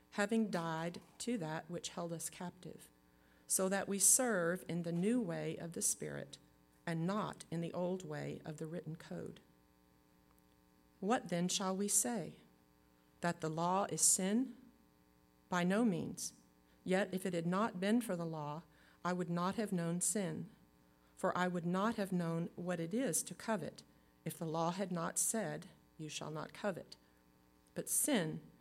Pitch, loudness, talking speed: 170 Hz, -38 LUFS, 170 wpm